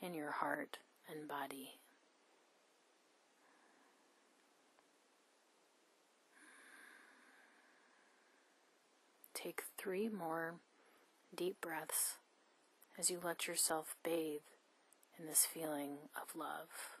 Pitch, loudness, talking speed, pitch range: 165 Hz, -42 LUFS, 70 wpm, 150-185 Hz